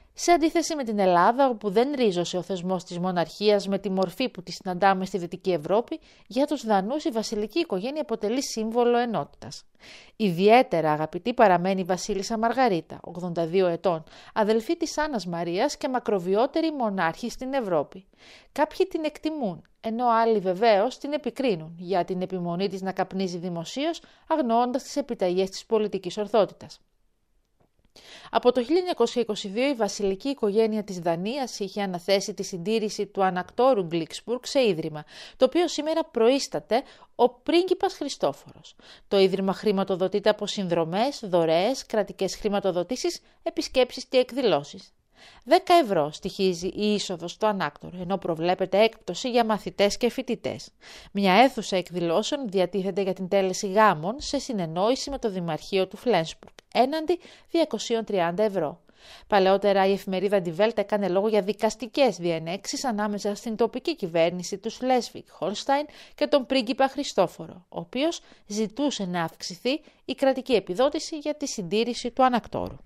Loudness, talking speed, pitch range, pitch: -25 LUFS, 140 wpm, 190-255 Hz, 210 Hz